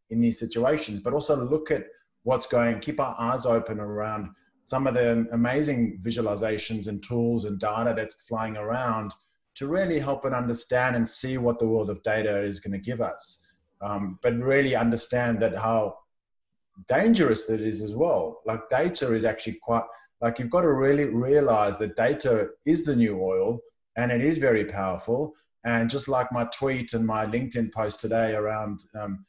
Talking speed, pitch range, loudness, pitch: 180 wpm, 110-130 Hz, -26 LUFS, 115 Hz